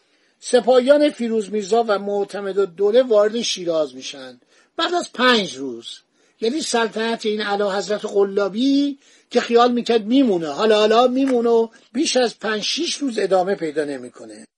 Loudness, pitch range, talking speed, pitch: -19 LUFS, 200-250 Hz, 150 wpm, 220 Hz